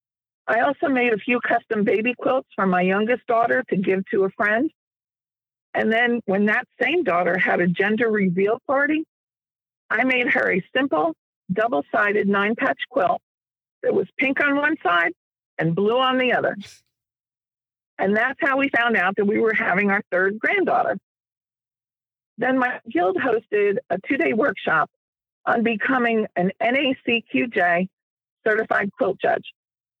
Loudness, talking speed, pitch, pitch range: -21 LUFS, 155 wpm, 225 Hz, 190-260 Hz